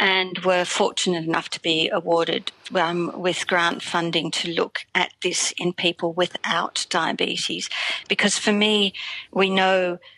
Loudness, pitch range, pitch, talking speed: -22 LUFS, 170-190 Hz, 180 Hz, 140 wpm